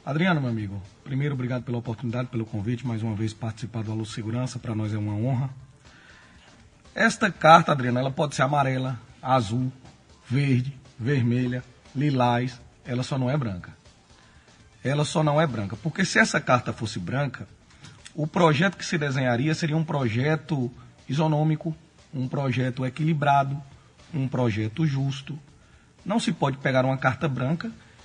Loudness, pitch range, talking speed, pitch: -25 LUFS, 120-150 Hz, 150 wpm, 130 Hz